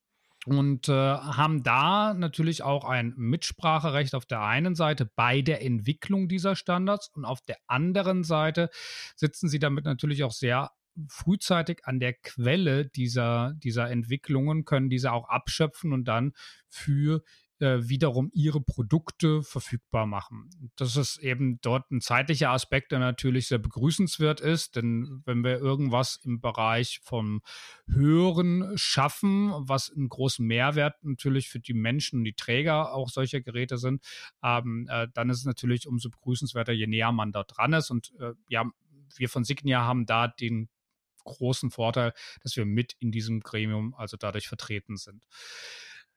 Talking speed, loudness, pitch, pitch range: 150 wpm, -28 LUFS, 130 Hz, 120-150 Hz